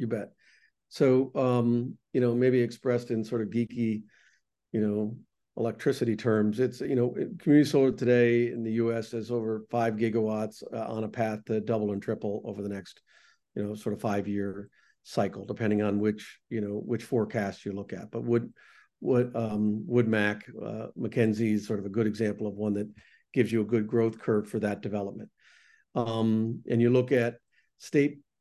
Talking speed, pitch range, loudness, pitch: 190 wpm, 105-120 Hz, -29 LUFS, 115 Hz